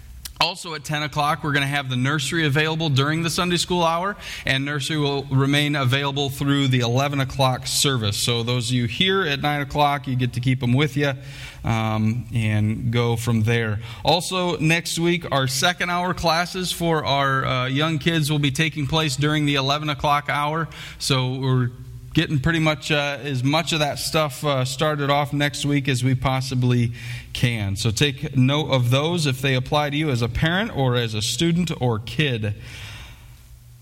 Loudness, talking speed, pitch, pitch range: -21 LUFS, 190 wpm, 140 Hz, 125-155 Hz